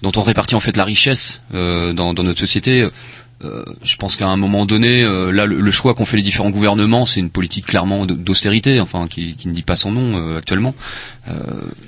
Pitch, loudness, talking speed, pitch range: 100 Hz, -15 LUFS, 225 wpm, 95-115 Hz